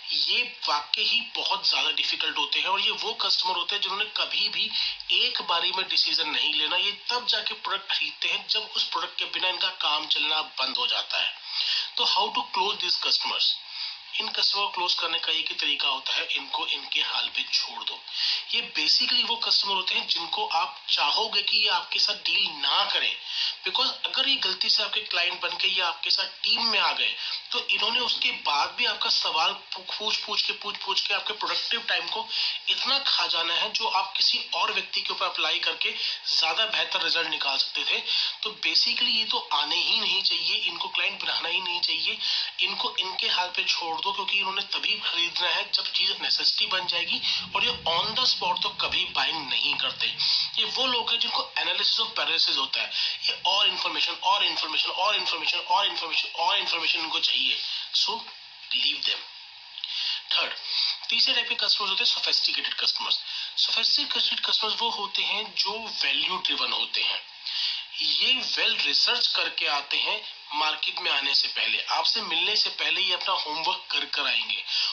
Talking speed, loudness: 185 wpm, -24 LUFS